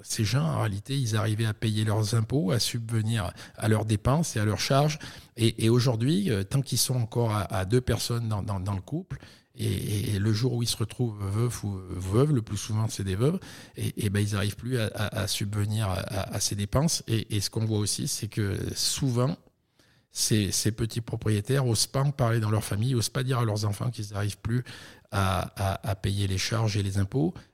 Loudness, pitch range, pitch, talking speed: -28 LUFS, 105-125 Hz, 110 Hz, 230 wpm